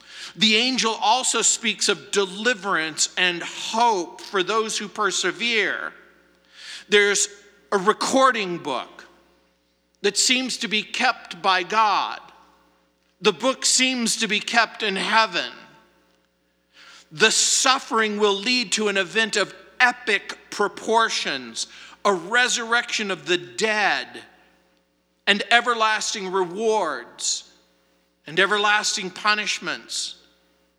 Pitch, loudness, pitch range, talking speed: 210 Hz, -21 LUFS, 180-225 Hz, 100 wpm